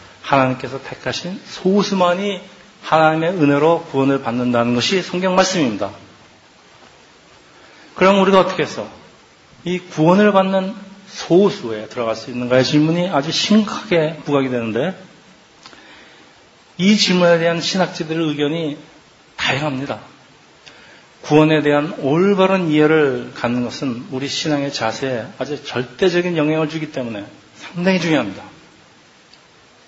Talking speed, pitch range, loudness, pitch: 285 characters per minute, 135-180 Hz, -17 LUFS, 155 Hz